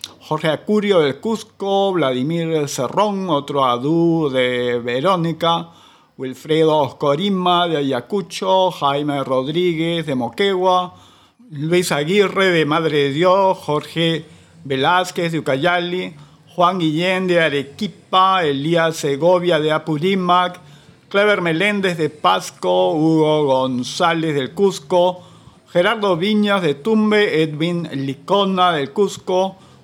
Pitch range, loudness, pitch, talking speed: 150-185 Hz, -17 LUFS, 170 Hz, 105 wpm